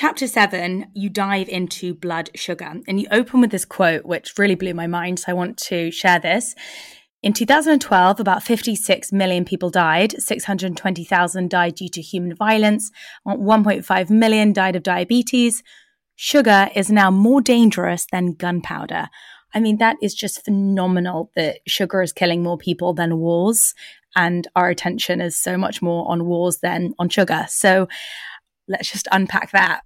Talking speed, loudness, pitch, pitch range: 160 wpm, -18 LUFS, 190 Hz, 175-215 Hz